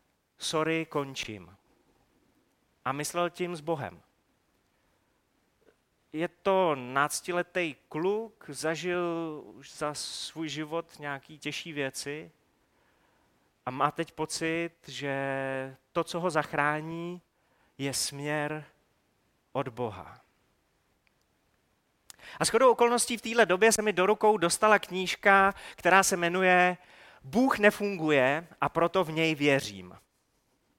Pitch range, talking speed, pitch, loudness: 145-180 Hz, 105 wpm, 160 Hz, -28 LUFS